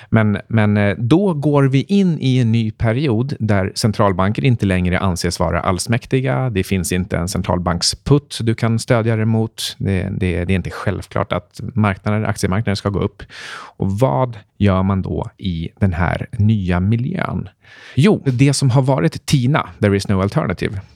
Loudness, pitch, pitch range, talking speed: -18 LUFS, 105 Hz, 95-125 Hz, 165 wpm